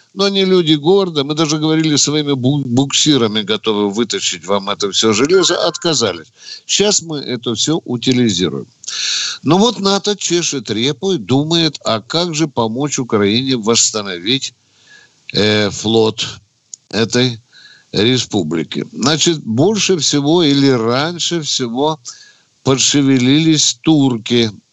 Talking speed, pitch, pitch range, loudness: 110 wpm, 135 Hz, 115-160 Hz, -14 LUFS